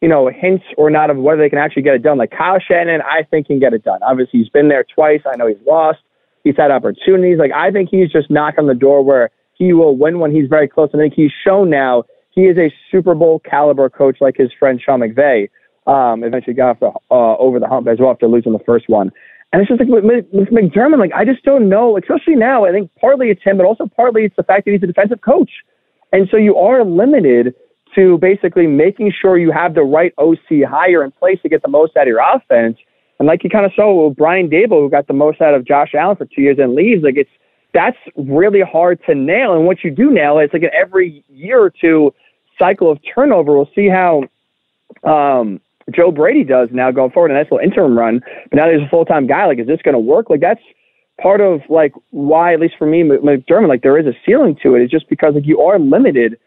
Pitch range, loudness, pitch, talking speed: 140-195 Hz, -12 LUFS, 160 Hz, 250 wpm